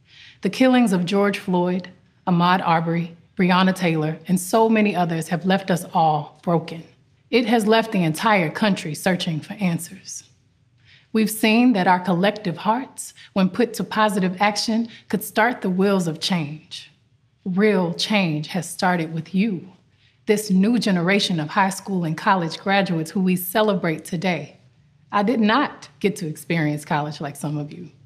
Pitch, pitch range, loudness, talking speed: 180 Hz, 160-205 Hz, -21 LUFS, 160 wpm